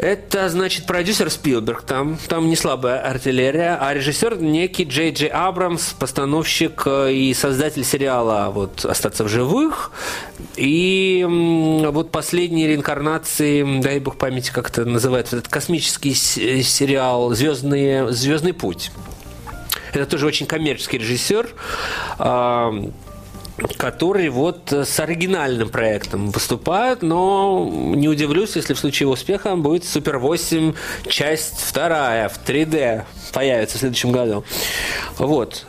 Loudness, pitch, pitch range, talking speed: -19 LUFS, 145 Hz, 125-165 Hz, 115 wpm